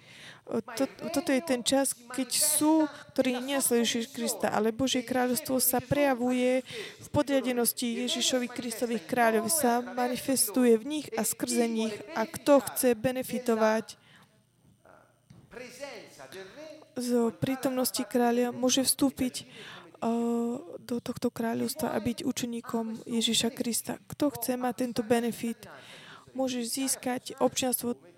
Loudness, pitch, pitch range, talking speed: -28 LUFS, 245 Hz, 230-260 Hz, 110 wpm